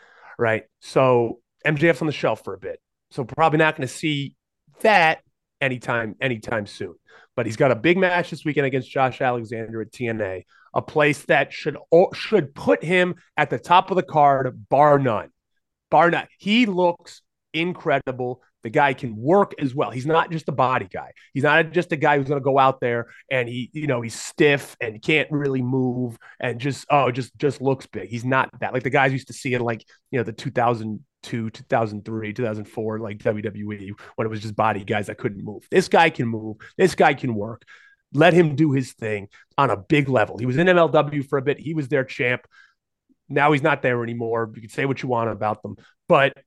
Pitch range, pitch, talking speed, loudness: 115-150 Hz, 130 Hz, 215 wpm, -21 LUFS